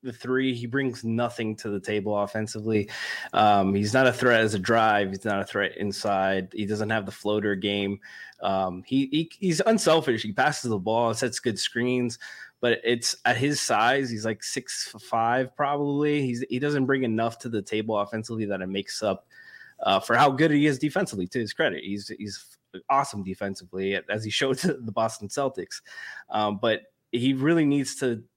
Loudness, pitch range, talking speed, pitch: -26 LUFS, 105-130 Hz, 190 wpm, 115 Hz